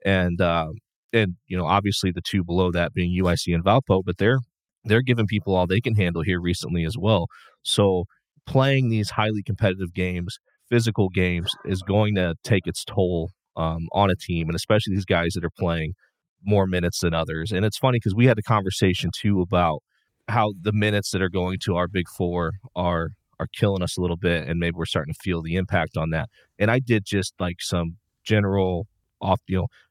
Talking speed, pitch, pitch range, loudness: 205 wpm, 95 Hz, 85-105 Hz, -23 LUFS